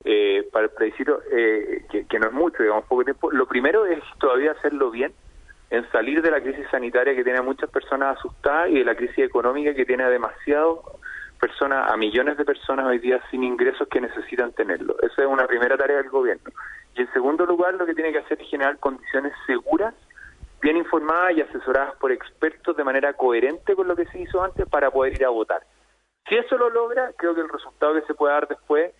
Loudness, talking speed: -22 LUFS, 215 wpm